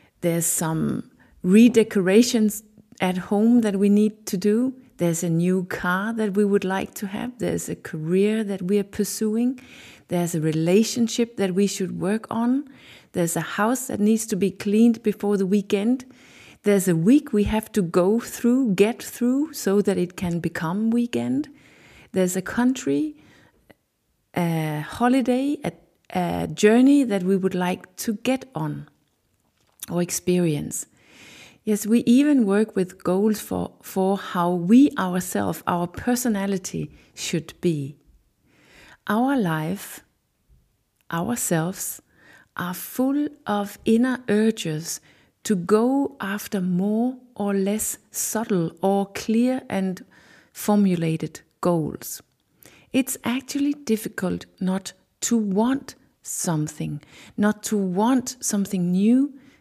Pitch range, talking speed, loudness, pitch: 180-235 Hz, 125 wpm, -23 LUFS, 205 Hz